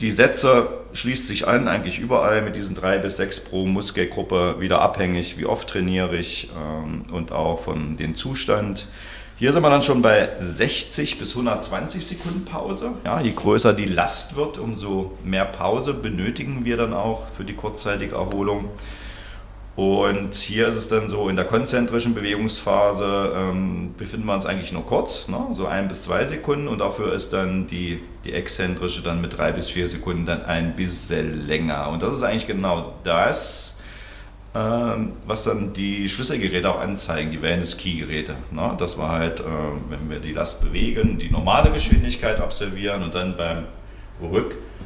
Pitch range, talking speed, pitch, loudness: 85-105 Hz, 170 wpm, 95 Hz, -23 LUFS